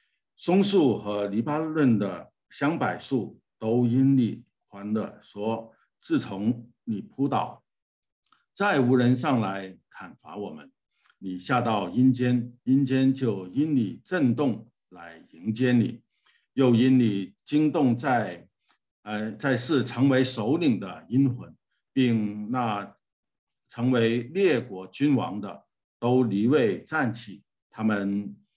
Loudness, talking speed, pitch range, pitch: -25 LUFS, 165 characters per minute, 110-130 Hz, 120 Hz